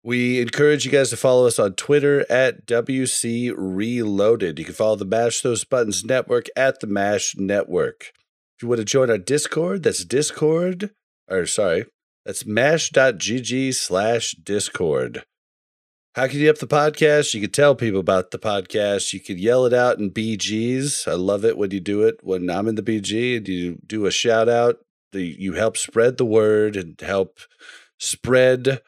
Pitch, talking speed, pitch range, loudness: 120 Hz, 175 wpm, 105-130 Hz, -20 LUFS